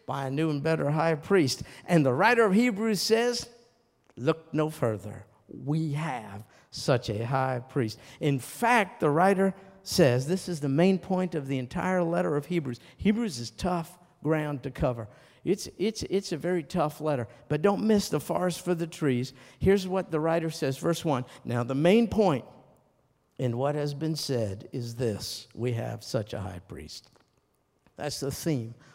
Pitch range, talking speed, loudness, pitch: 130-180 Hz, 180 wpm, -28 LUFS, 155 Hz